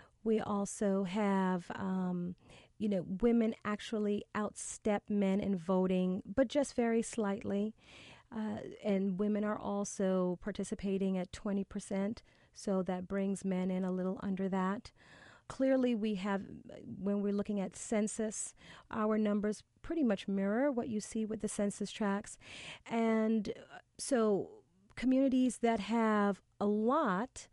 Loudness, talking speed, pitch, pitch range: -35 LUFS, 130 wpm, 205 Hz, 195-220 Hz